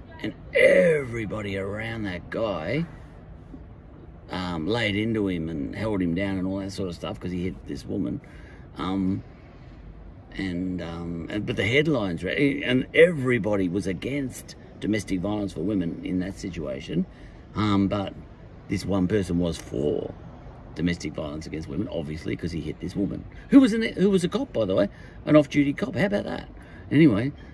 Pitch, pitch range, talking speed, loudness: 100 Hz, 90-125 Hz, 170 wpm, -25 LUFS